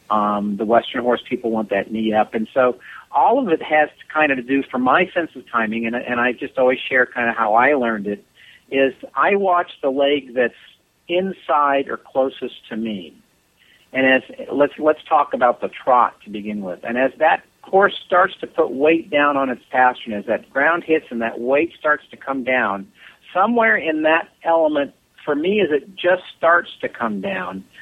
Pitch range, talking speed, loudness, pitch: 115-155 Hz, 205 wpm, -19 LUFS, 130 Hz